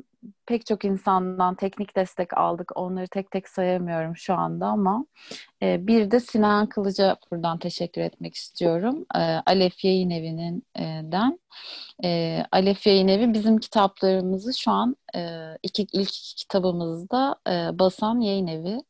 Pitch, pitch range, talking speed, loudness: 190 Hz, 175-215 Hz, 140 wpm, -24 LUFS